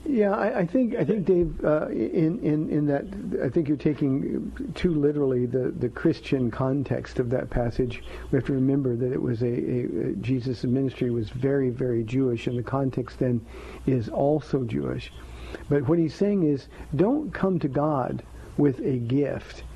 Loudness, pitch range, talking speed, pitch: -26 LUFS, 125-155 Hz, 180 wpm, 135 Hz